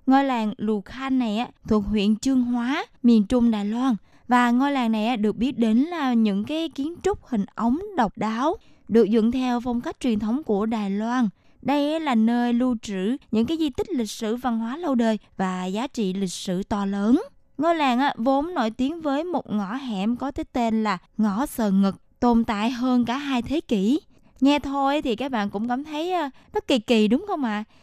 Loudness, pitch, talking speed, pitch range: -24 LUFS, 245 Hz, 215 wpm, 220-275 Hz